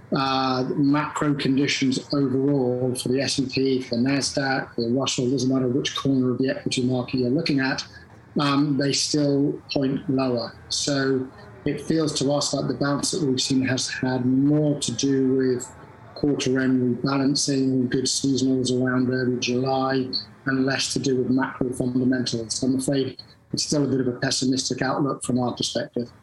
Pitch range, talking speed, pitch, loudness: 125-140 Hz, 165 wpm, 130 Hz, -23 LUFS